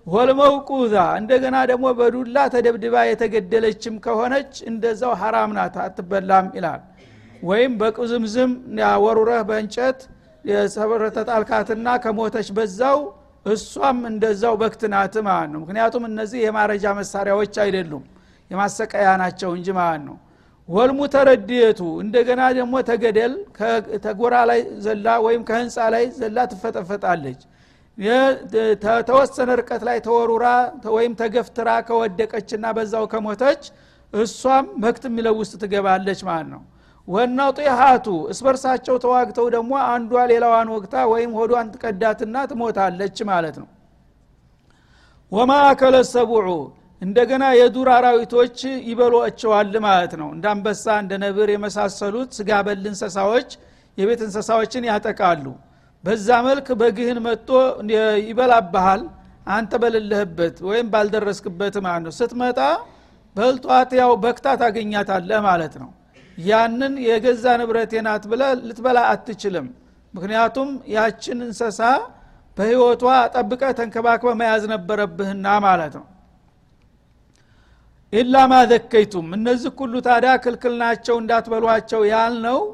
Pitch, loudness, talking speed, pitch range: 230 Hz, -19 LUFS, 100 wpm, 210-245 Hz